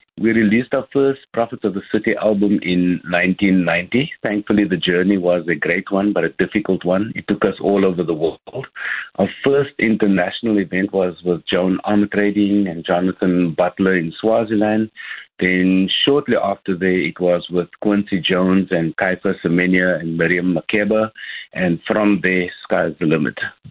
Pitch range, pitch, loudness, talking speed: 90-105 Hz, 95 Hz, -18 LUFS, 160 wpm